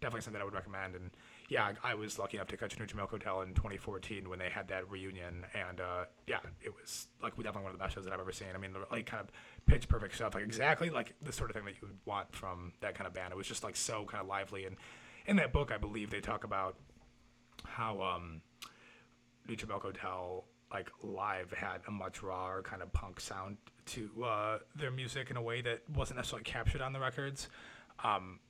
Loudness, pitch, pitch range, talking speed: -40 LUFS, 100 Hz, 95-115 Hz, 235 wpm